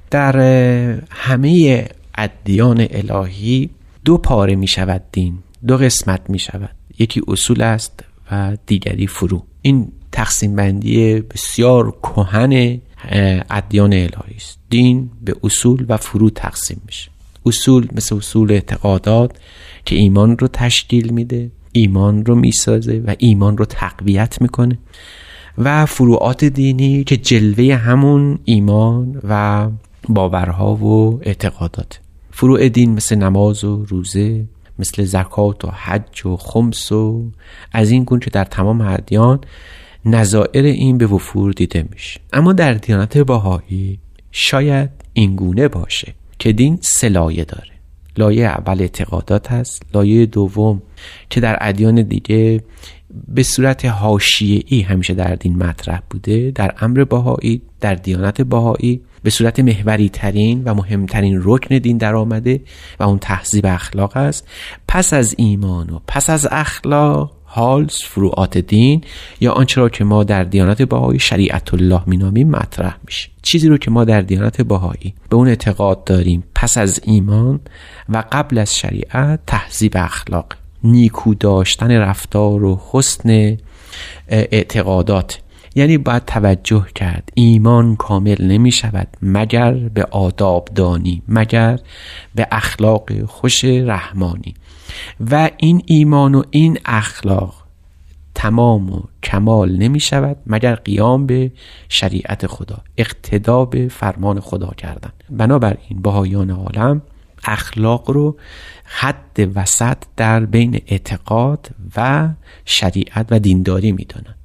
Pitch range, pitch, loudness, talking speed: 95-120 Hz, 105 Hz, -14 LUFS, 130 wpm